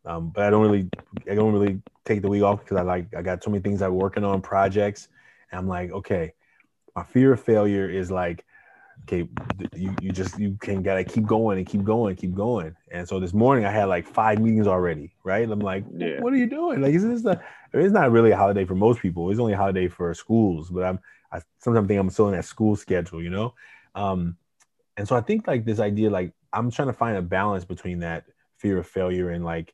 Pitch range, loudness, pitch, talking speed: 90-110 Hz, -24 LUFS, 100 Hz, 245 wpm